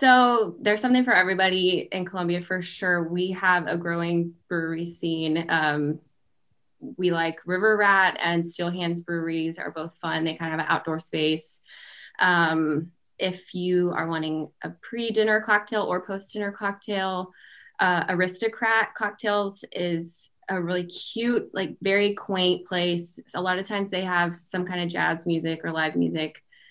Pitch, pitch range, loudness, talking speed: 180 Hz, 165-195 Hz, -25 LUFS, 155 wpm